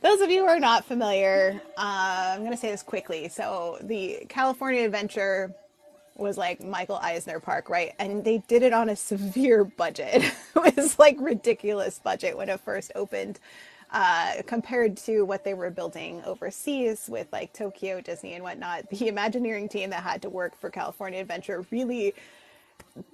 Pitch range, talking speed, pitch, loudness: 190-245 Hz, 170 wpm, 210 Hz, -26 LUFS